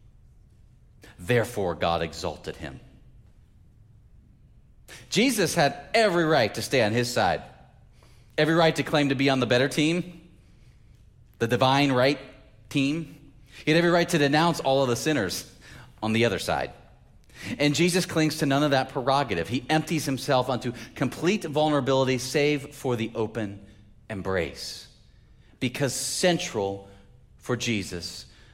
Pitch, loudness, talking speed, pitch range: 130 Hz, -25 LUFS, 135 wpm, 115-150 Hz